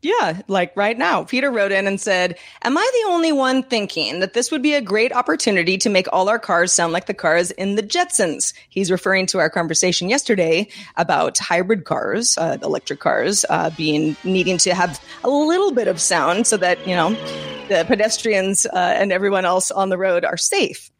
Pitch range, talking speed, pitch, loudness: 180-240 Hz, 205 wpm, 195 Hz, -18 LUFS